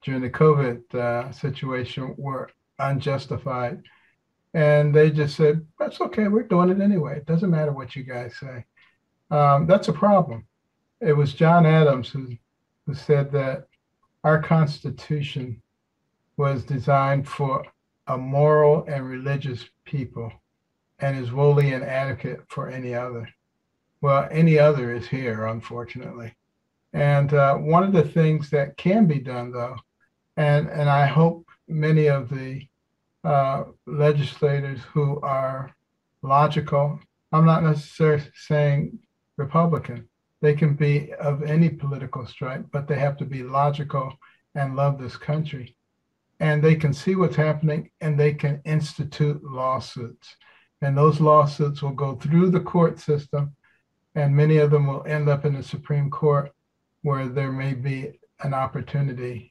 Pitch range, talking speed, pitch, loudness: 135-155 Hz, 140 wpm, 145 Hz, -22 LUFS